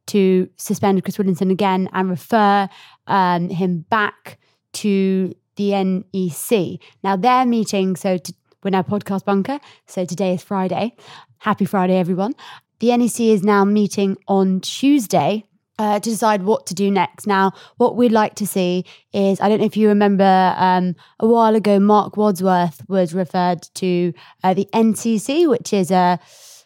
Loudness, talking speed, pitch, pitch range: -18 LUFS, 160 wpm, 195 Hz, 185-210 Hz